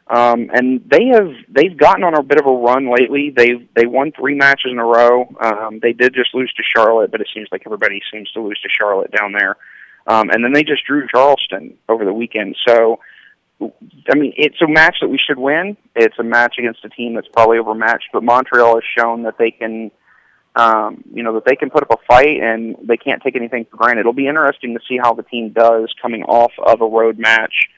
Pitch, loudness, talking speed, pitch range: 120 Hz, -13 LUFS, 235 wpm, 115-130 Hz